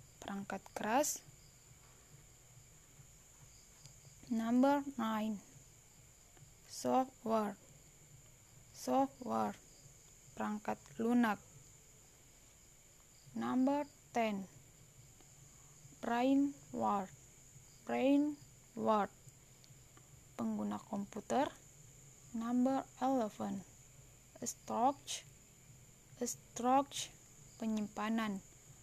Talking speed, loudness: 45 wpm, -38 LUFS